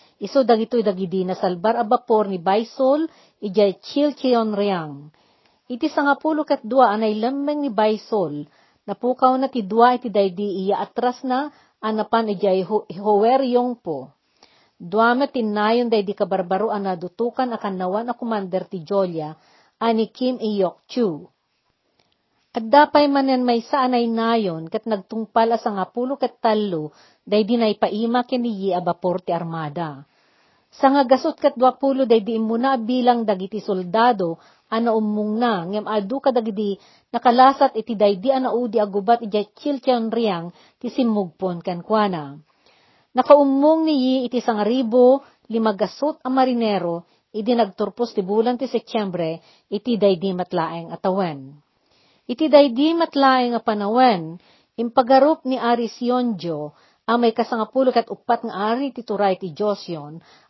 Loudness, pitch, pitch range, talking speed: -20 LUFS, 225 Hz, 195-250 Hz, 135 wpm